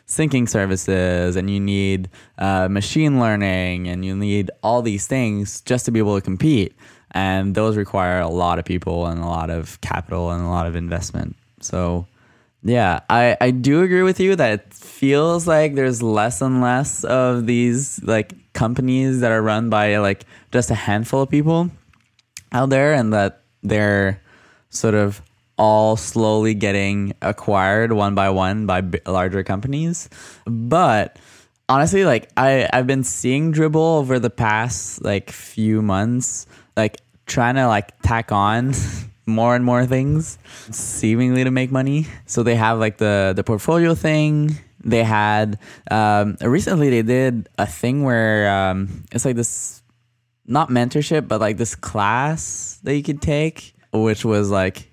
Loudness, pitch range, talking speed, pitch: -19 LUFS, 100-125 Hz, 160 wpm, 110 Hz